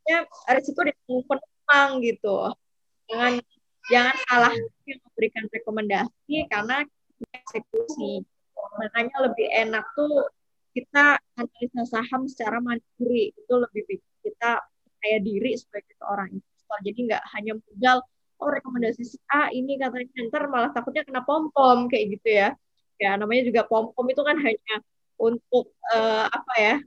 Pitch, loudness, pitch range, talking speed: 245 Hz, -24 LUFS, 225-275 Hz, 140 wpm